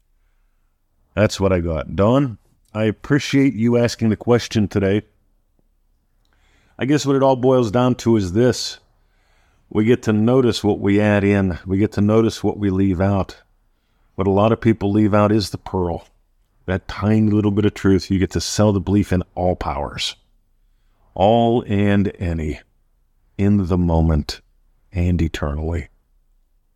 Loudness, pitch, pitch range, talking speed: -18 LUFS, 100 Hz, 90-110 Hz, 160 wpm